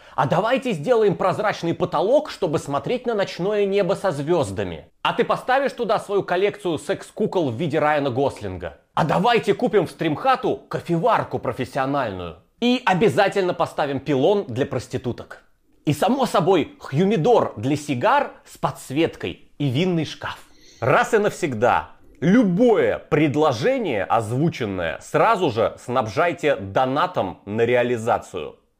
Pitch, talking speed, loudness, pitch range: 165 Hz, 125 wpm, -21 LUFS, 140-200 Hz